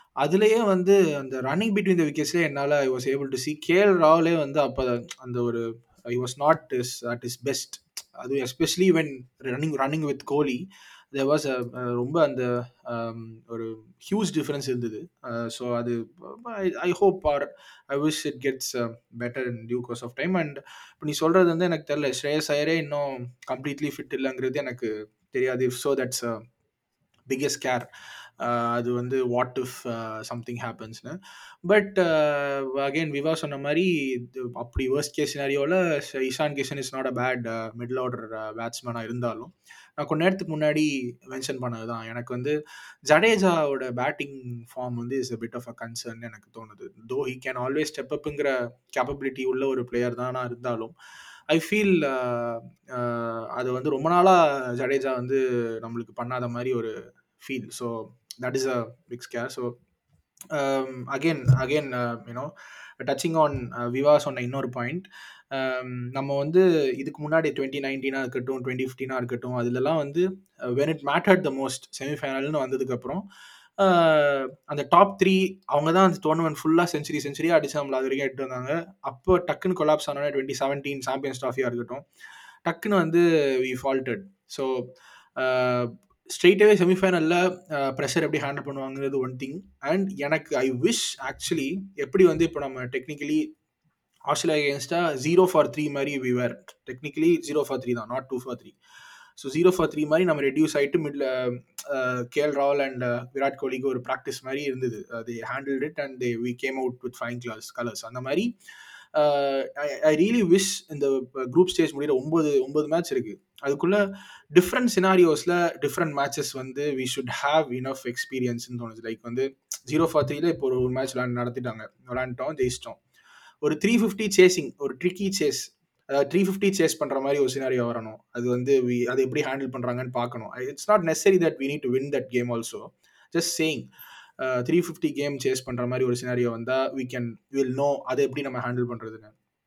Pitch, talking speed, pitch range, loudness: 135 Hz, 160 wpm, 125-155 Hz, -26 LUFS